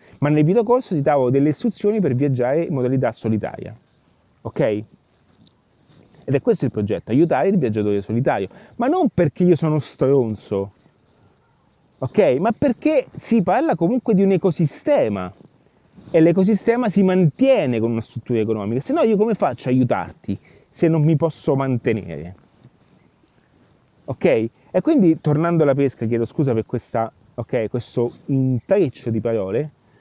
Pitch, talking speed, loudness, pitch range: 140 Hz, 145 wpm, -19 LUFS, 115-180 Hz